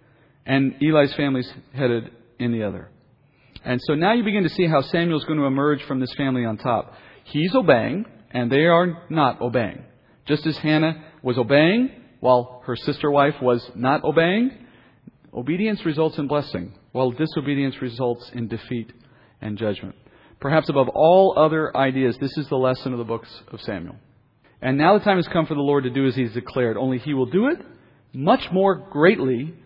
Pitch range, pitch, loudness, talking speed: 125-155 Hz, 140 Hz, -21 LUFS, 190 wpm